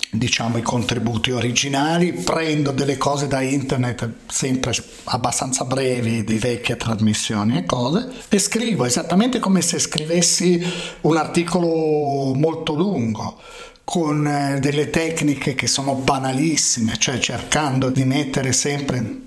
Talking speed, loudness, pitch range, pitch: 120 wpm, -20 LUFS, 120-160 Hz, 140 Hz